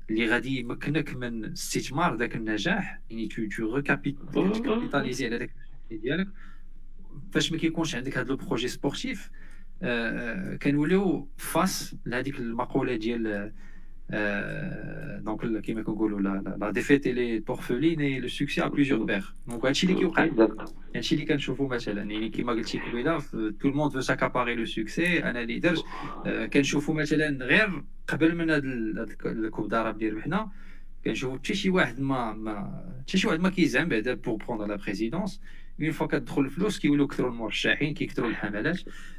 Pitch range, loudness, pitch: 115-160 Hz, -28 LUFS, 140 Hz